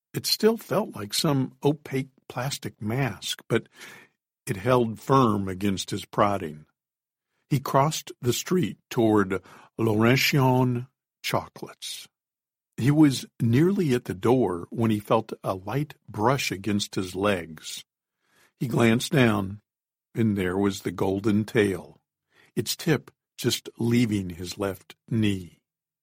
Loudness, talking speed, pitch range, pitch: -25 LUFS, 120 wpm, 100-135 Hz, 115 Hz